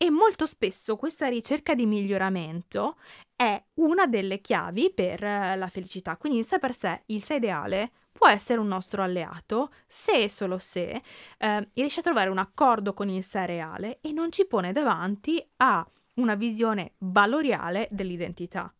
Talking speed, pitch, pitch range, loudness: 165 wpm, 210 Hz, 190-265 Hz, -27 LUFS